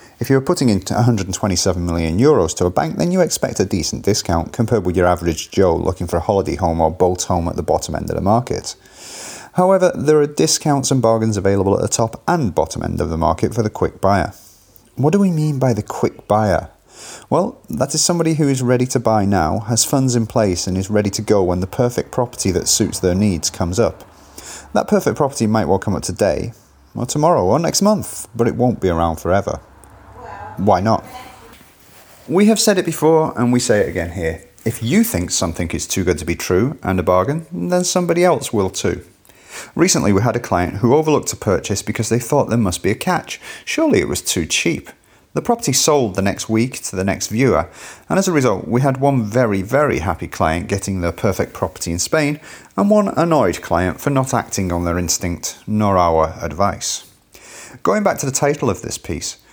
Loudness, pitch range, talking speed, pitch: -17 LUFS, 90-135 Hz, 215 wpm, 110 Hz